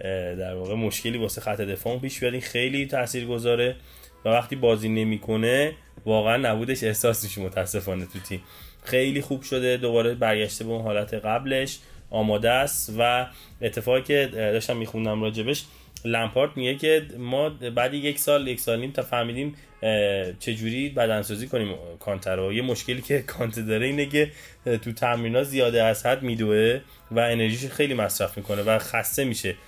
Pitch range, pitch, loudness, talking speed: 105-130 Hz, 115 Hz, -25 LUFS, 150 wpm